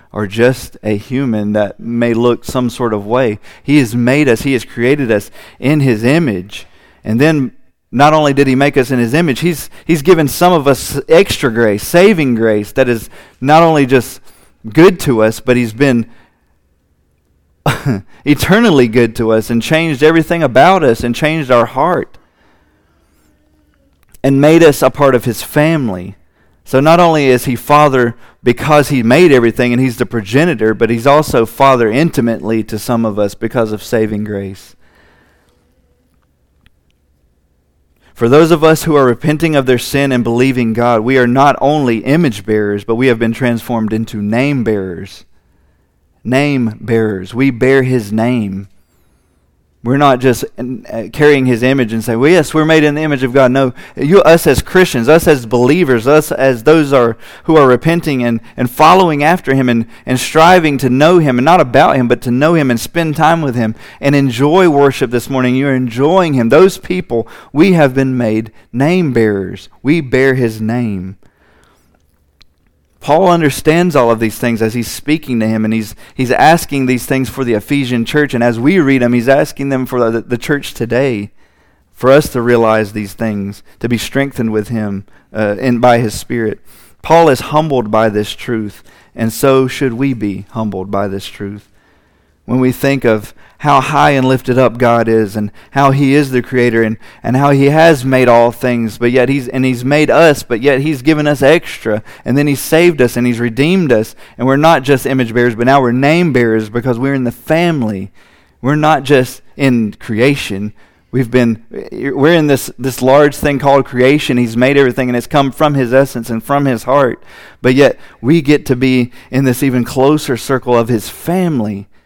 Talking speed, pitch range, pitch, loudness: 185 wpm, 110-140 Hz, 125 Hz, -11 LUFS